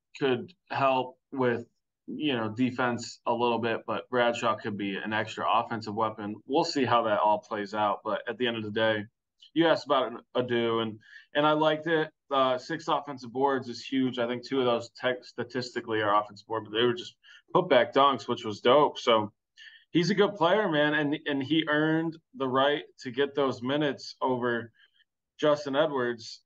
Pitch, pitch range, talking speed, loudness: 125 Hz, 115-145 Hz, 195 wpm, -28 LUFS